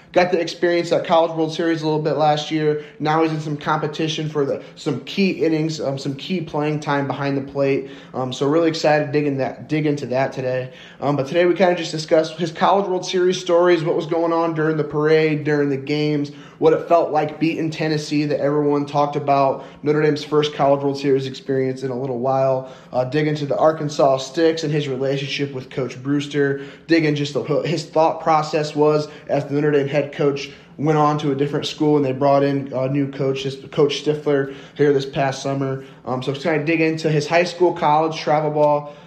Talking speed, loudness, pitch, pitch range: 220 wpm, -20 LUFS, 150 Hz, 140-160 Hz